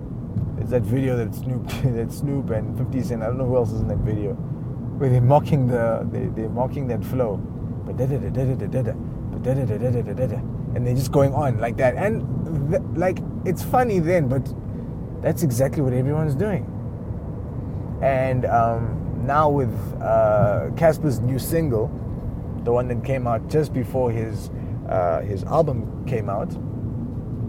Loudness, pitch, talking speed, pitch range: -23 LUFS, 125 Hz, 140 wpm, 115-135 Hz